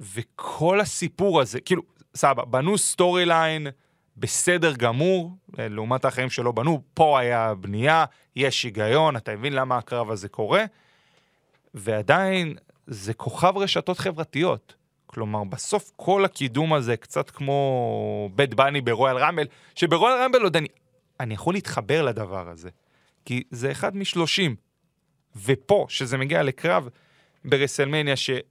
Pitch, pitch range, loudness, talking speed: 140 Hz, 125-170 Hz, -23 LUFS, 125 wpm